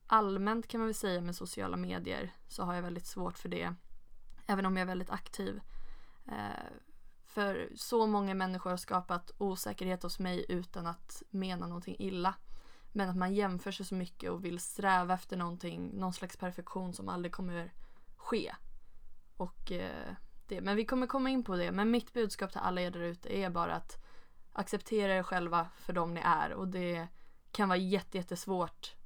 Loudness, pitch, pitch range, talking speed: -36 LUFS, 185 Hz, 175-200 Hz, 175 wpm